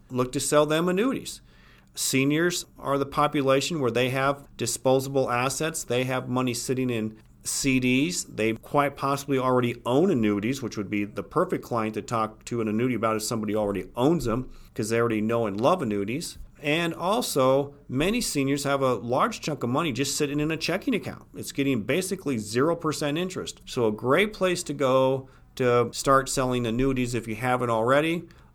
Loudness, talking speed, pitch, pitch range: -26 LUFS, 180 wpm, 130 Hz, 115-145 Hz